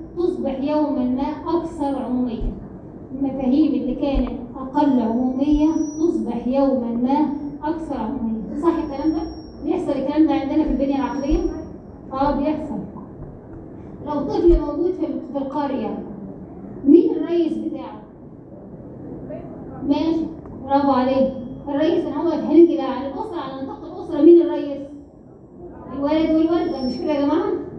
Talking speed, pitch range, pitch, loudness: 125 wpm, 275-320 Hz, 290 Hz, -20 LUFS